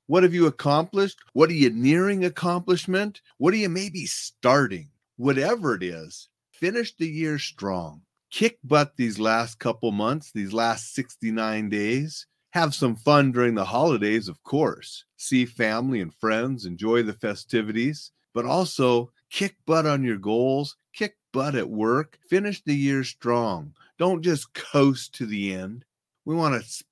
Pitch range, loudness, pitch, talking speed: 115-160 Hz, -24 LUFS, 135 Hz, 160 wpm